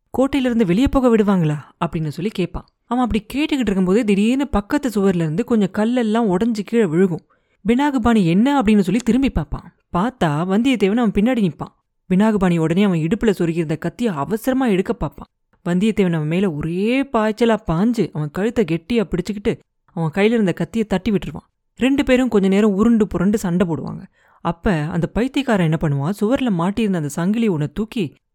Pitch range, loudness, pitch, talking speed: 170-230 Hz, -19 LUFS, 205 Hz, 125 wpm